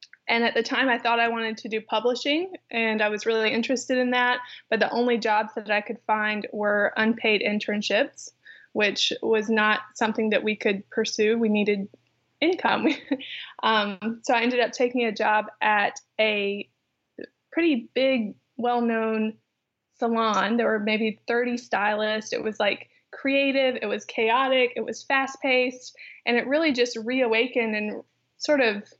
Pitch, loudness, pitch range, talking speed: 230 Hz, -24 LUFS, 215-250 Hz, 165 wpm